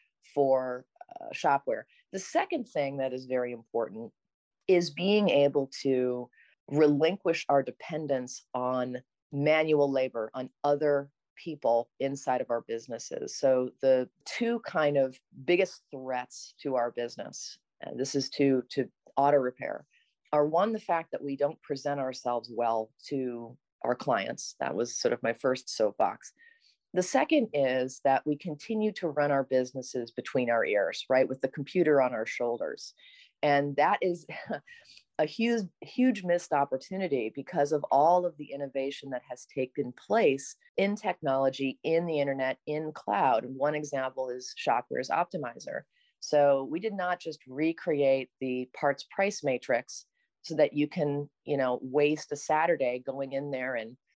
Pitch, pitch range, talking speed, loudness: 140 Hz, 130-165 Hz, 150 wpm, -30 LUFS